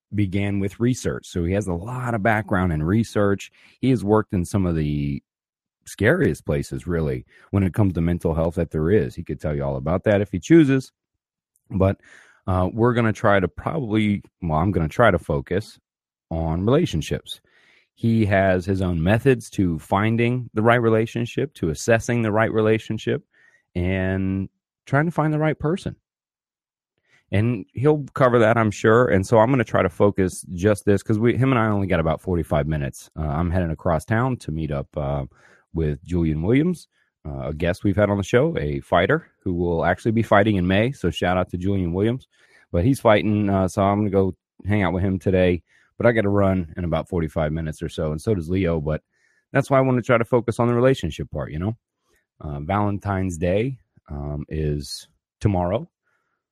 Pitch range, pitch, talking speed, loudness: 85-115 Hz, 100 Hz, 205 wpm, -22 LUFS